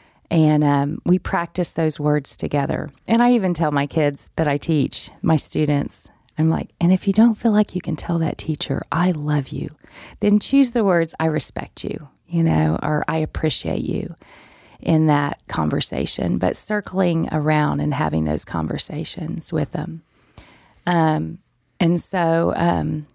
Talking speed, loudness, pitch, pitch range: 165 wpm, -20 LUFS, 160 Hz, 145-175 Hz